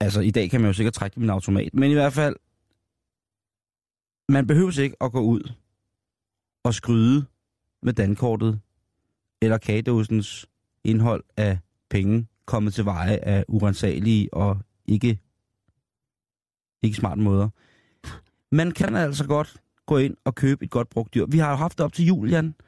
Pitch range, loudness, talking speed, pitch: 100-130 Hz, -23 LUFS, 155 wpm, 110 Hz